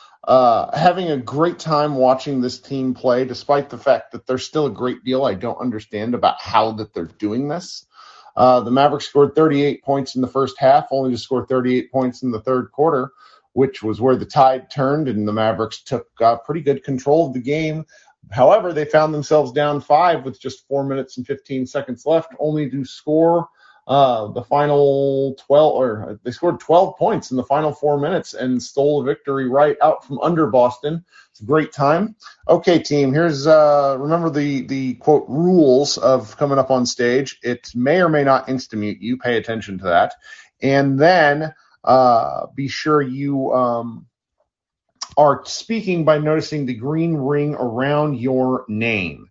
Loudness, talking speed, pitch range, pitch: -18 LUFS, 185 wpm, 125-150 Hz, 140 Hz